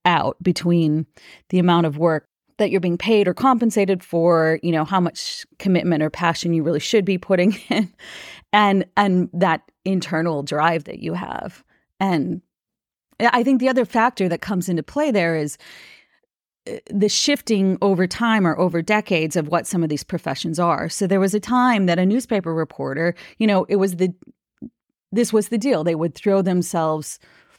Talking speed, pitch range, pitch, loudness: 180 wpm, 170-210 Hz, 185 Hz, -20 LUFS